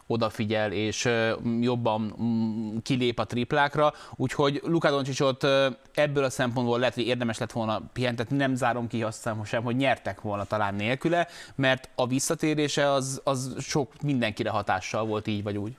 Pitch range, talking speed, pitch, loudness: 110-135 Hz, 150 wpm, 120 Hz, -27 LUFS